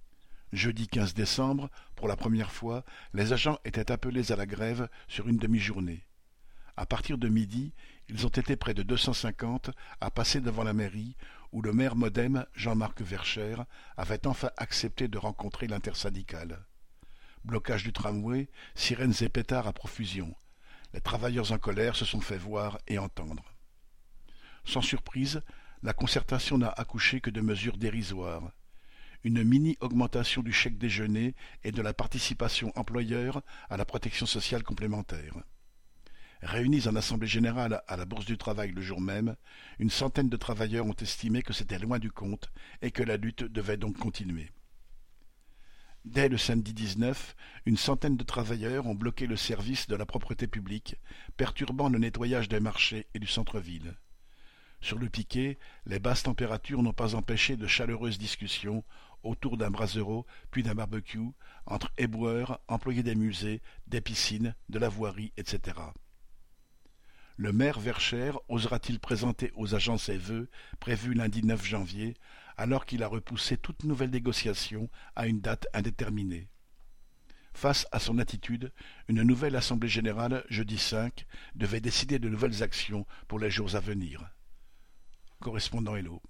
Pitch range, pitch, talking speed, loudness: 105-125 Hz, 115 Hz, 155 wpm, -32 LUFS